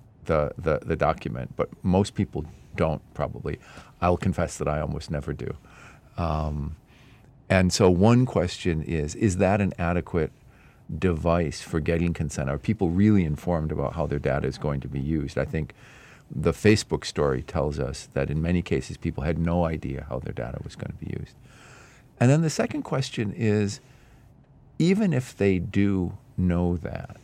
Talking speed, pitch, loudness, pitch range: 170 wpm, 90 Hz, -26 LUFS, 75-105 Hz